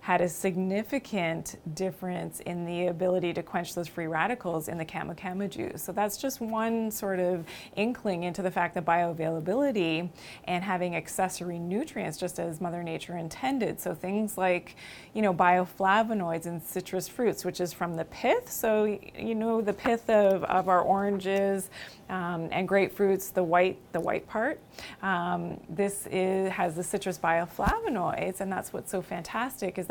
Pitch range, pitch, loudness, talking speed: 175-200 Hz, 185 Hz, -29 LUFS, 165 wpm